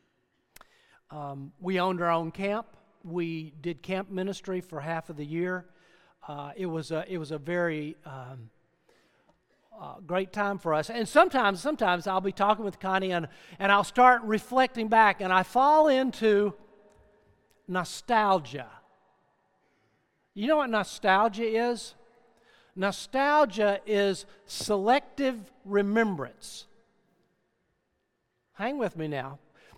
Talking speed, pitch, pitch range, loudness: 125 wpm, 195 Hz, 175-225 Hz, -27 LUFS